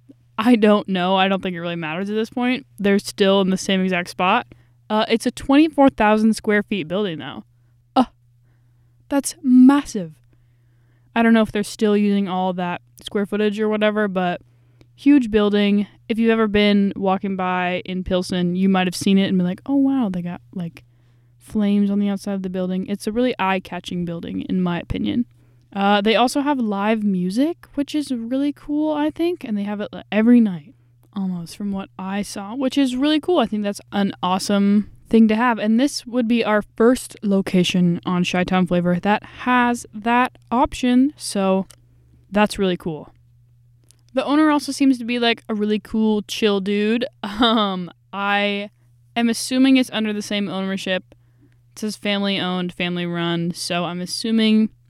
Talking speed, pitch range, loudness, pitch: 180 wpm, 180-225 Hz, -20 LUFS, 200 Hz